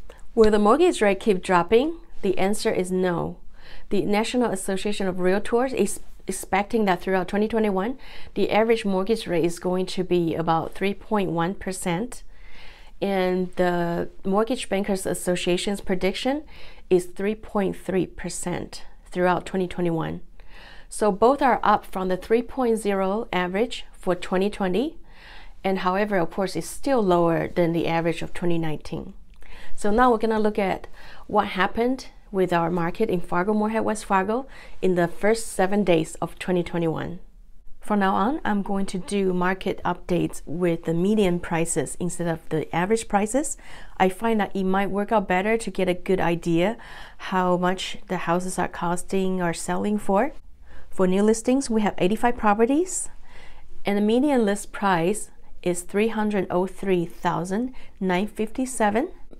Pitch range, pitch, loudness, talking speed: 180-215 Hz, 190 Hz, -24 LUFS, 140 wpm